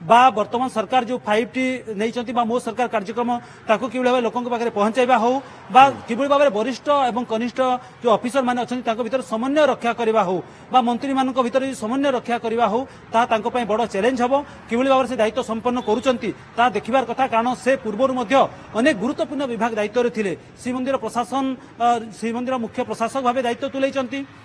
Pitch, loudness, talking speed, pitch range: 245 Hz, -21 LUFS, 95 wpm, 230-260 Hz